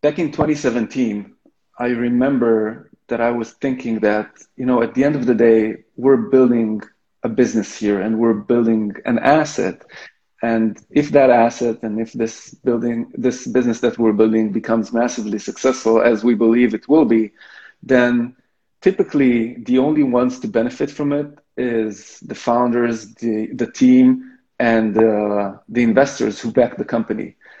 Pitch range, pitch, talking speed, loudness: 110-130 Hz, 120 Hz, 160 wpm, -17 LUFS